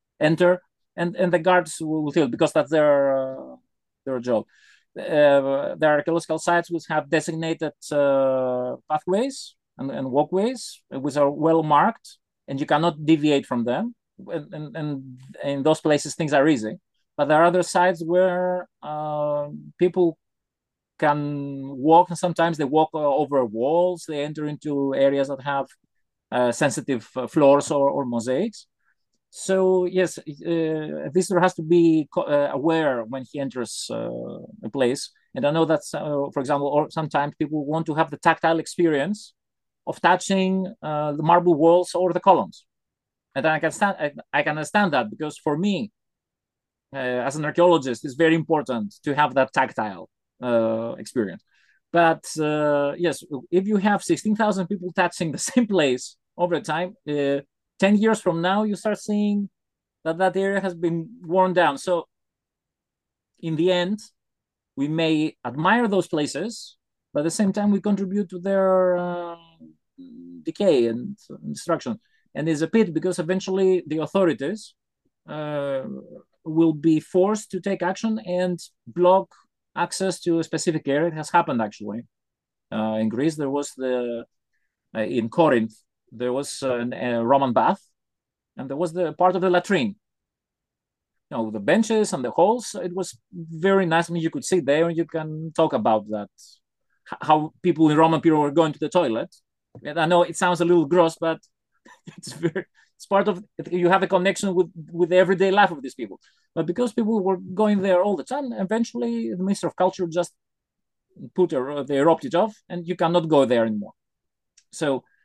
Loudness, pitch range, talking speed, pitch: -22 LUFS, 145-185 Hz, 170 wpm, 165 Hz